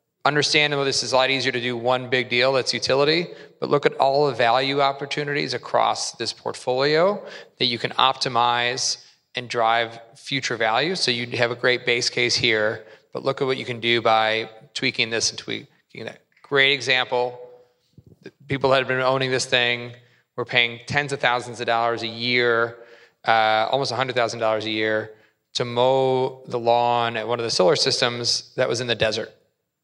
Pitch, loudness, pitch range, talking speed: 125 Hz, -21 LUFS, 115-130 Hz, 185 wpm